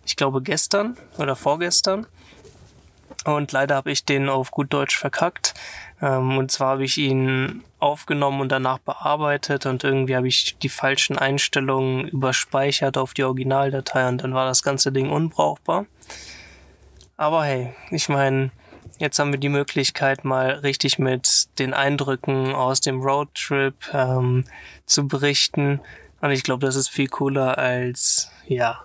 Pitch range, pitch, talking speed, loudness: 130-140 Hz, 135 Hz, 145 wpm, -20 LUFS